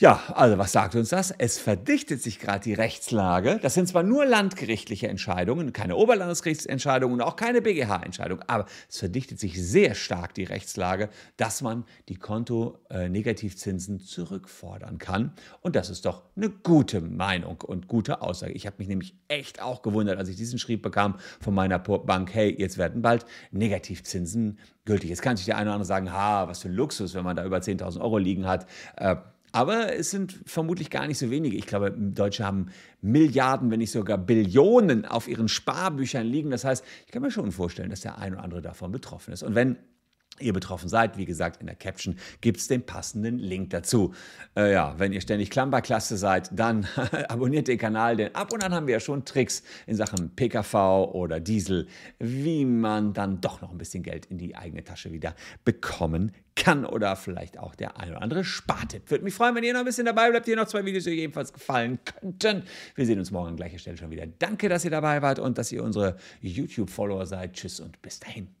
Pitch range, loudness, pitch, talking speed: 95-135 Hz, -27 LUFS, 110 Hz, 205 wpm